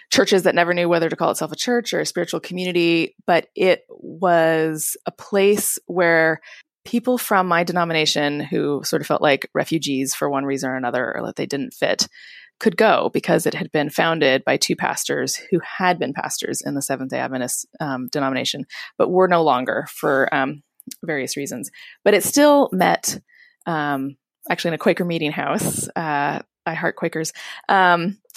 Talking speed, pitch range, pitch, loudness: 180 wpm, 145-185 Hz, 170 Hz, -20 LUFS